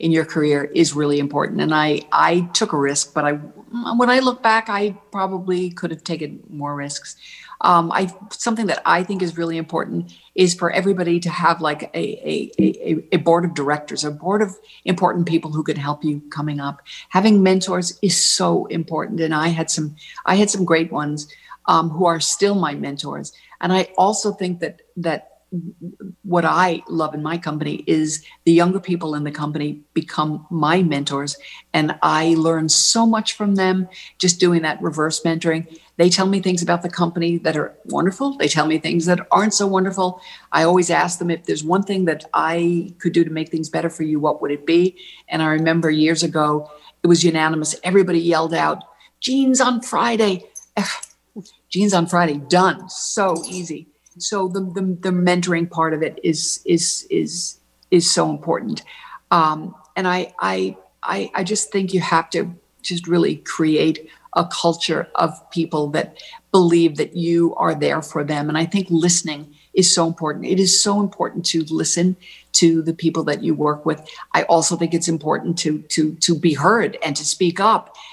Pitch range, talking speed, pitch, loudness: 155-185 Hz, 190 wpm, 170 Hz, -19 LUFS